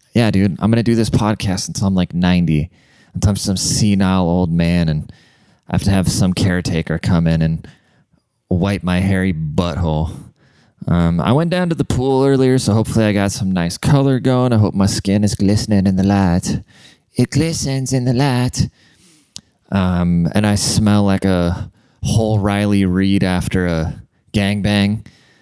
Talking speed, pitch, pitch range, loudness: 175 wpm, 100 Hz, 90-115 Hz, -16 LUFS